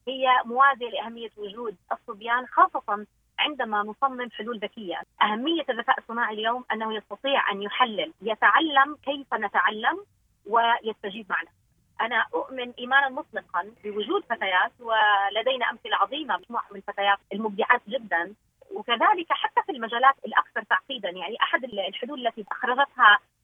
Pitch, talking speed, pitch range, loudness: 235 Hz, 125 wpm, 210-275 Hz, -25 LUFS